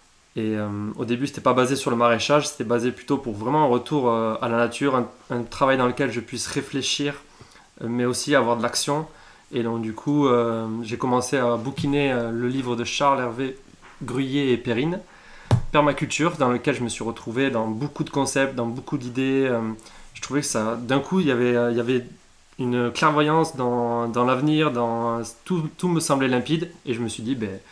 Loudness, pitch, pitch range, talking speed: -23 LUFS, 125 Hz, 120-140 Hz, 210 wpm